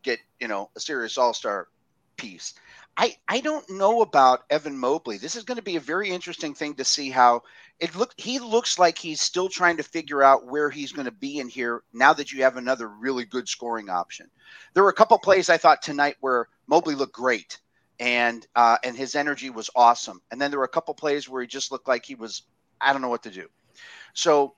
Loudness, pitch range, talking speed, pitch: -23 LUFS, 125-170 Hz, 225 wpm, 145 Hz